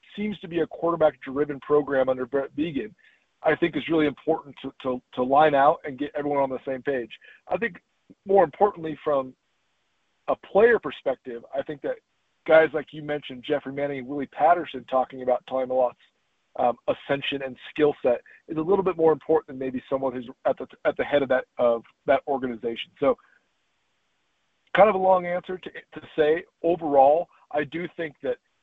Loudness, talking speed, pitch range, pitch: -25 LUFS, 185 wpm, 130-165 Hz, 145 Hz